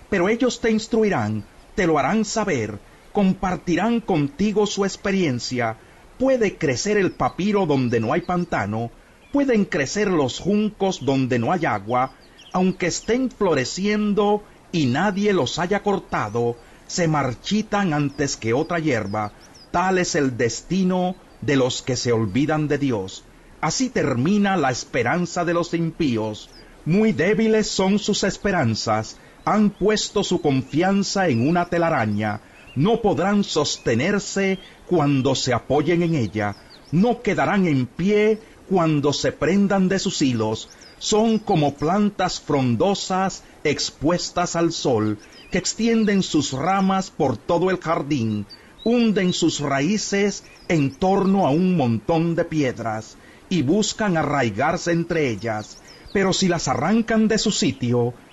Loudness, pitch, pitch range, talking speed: -21 LUFS, 175 Hz, 130-200 Hz, 130 wpm